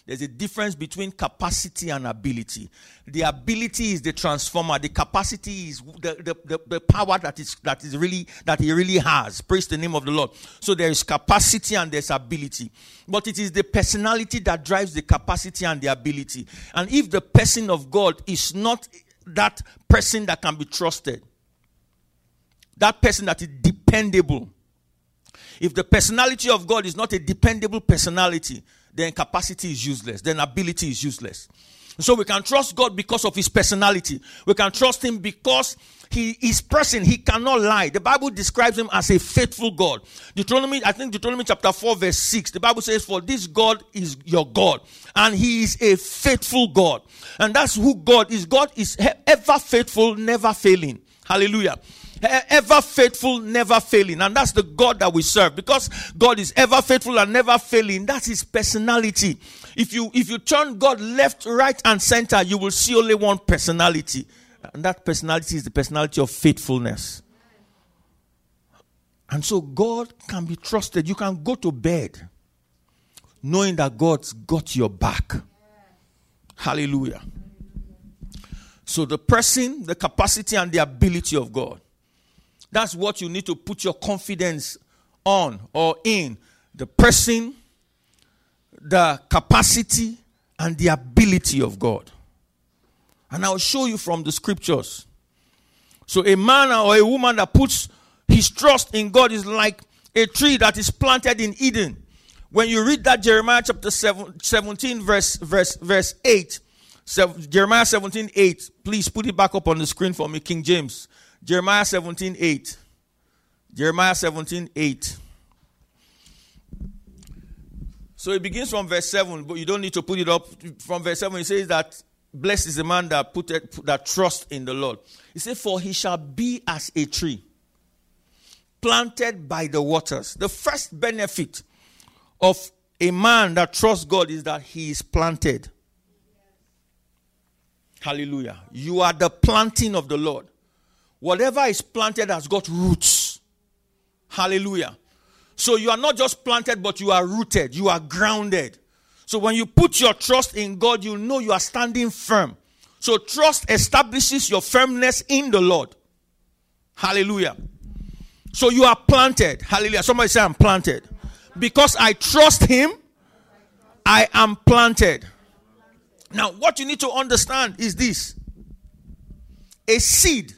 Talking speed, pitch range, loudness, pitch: 160 wpm, 155-225 Hz, -19 LUFS, 190 Hz